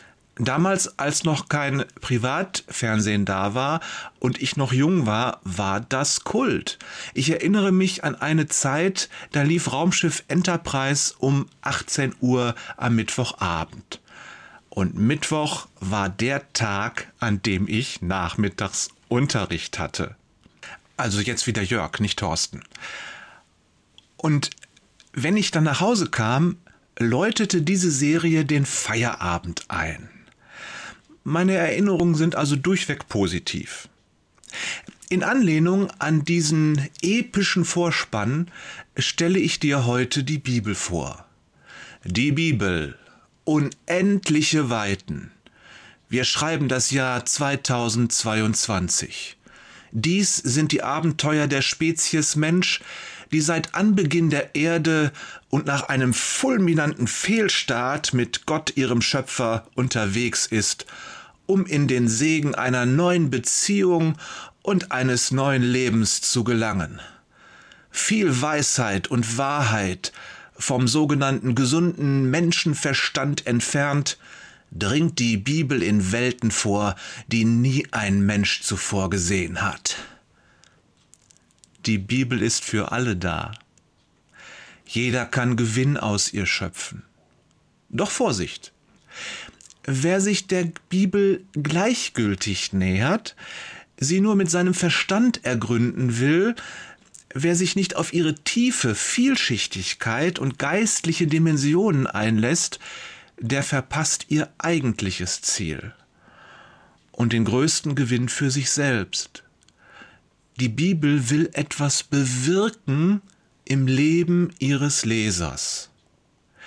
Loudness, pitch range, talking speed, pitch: -22 LUFS, 115-165 Hz, 105 wpm, 140 Hz